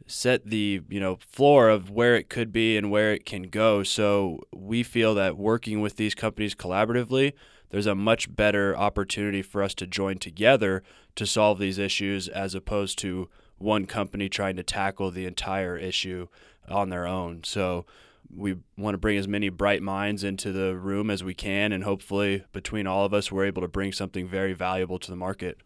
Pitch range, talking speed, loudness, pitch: 95-105 Hz, 195 wpm, -26 LUFS, 100 Hz